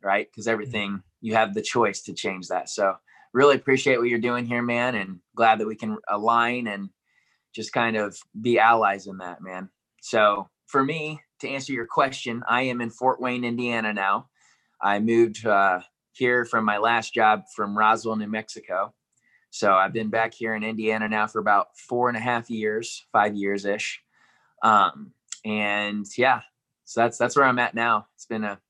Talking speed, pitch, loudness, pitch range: 185 wpm, 110 Hz, -24 LUFS, 105-120 Hz